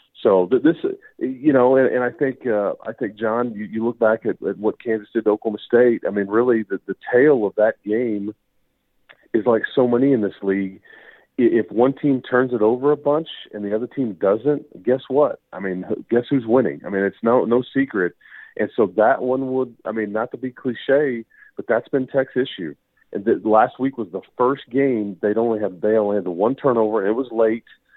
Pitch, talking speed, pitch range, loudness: 120 Hz, 210 wpm, 110-135 Hz, -20 LUFS